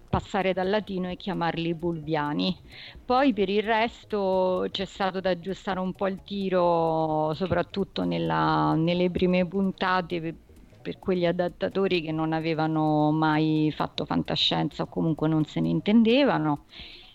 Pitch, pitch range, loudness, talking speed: 180 Hz, 155-190 Hz, -26 LUFS, 135 wpm